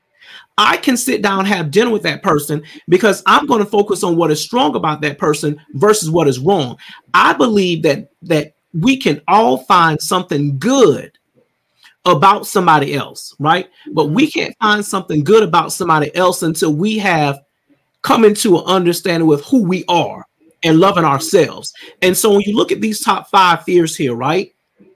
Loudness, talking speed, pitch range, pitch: -14 LUFS, 180 wpm, 160-210 Hz, 180 Hz